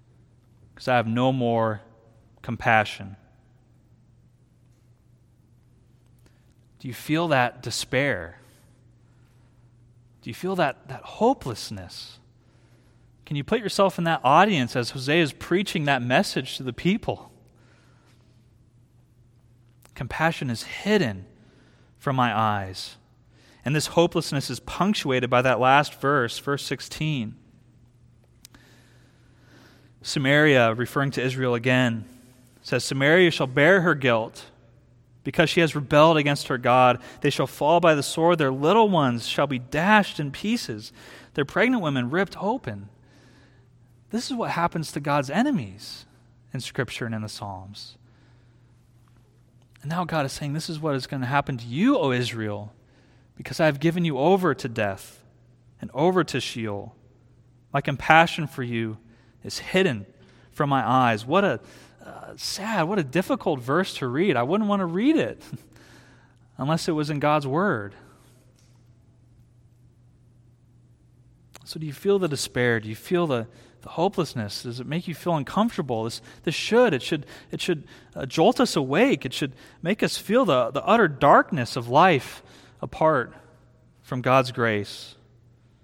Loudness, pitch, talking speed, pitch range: -23 LUFS, 125 Hz, 140 wpm, 120-150 Hz